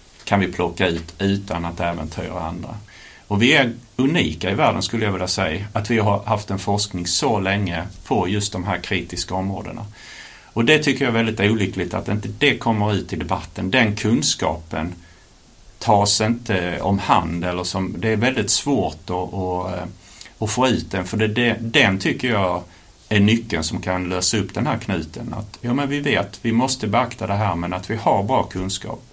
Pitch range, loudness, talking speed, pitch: 90-115 Hz, -20 LUFS, 190 wpm, 100 Hz